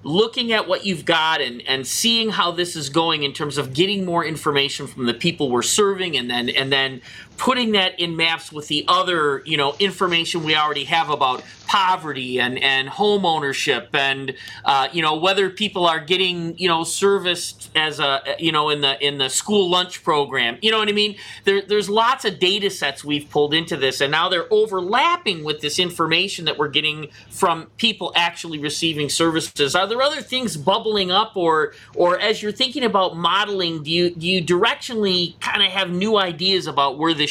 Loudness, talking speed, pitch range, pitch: -19 LUFS, 200 wpm, 150-195 Hz, 170 Hz